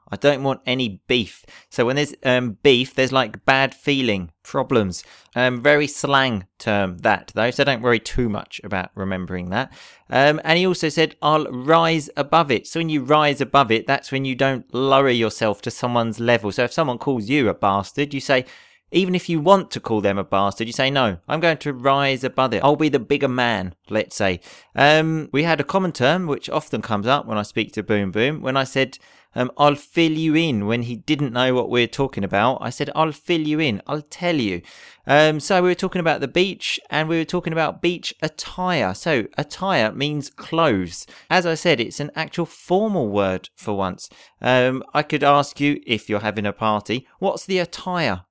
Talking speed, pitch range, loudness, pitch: 210 wpm, 115-155 Hz, -20 LUFS, 135 Hz